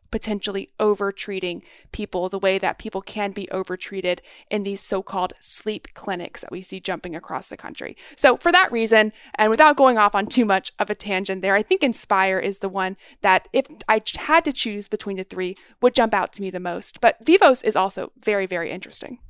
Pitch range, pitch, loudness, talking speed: 190-220 Hz, 200 Hz, -21 LUFS, 205 wpm